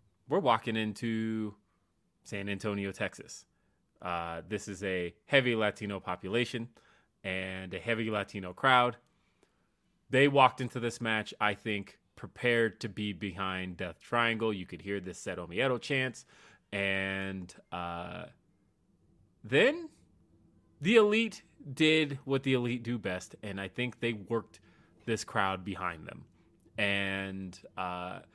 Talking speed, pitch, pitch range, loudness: 125 wpm, 105 Hz, 95-120 Hz, -32 LUFS